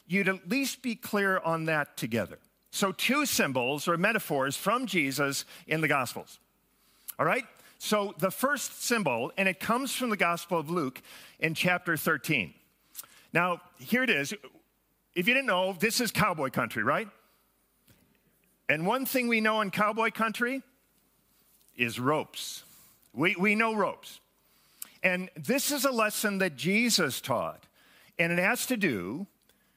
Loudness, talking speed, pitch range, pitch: -28 LUFS, 150 wpm, 170-230 Hz, 190 Hz